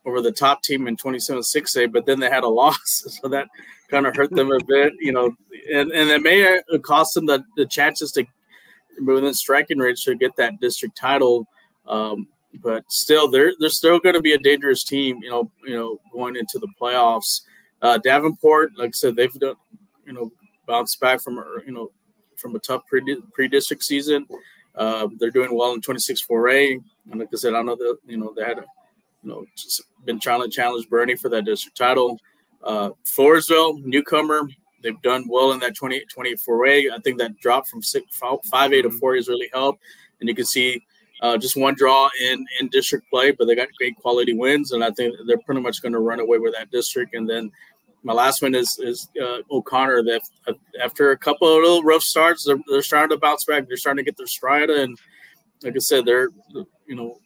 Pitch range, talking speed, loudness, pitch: 120-155 Hz, 210 wpm, -19 LUFS, 135 Hz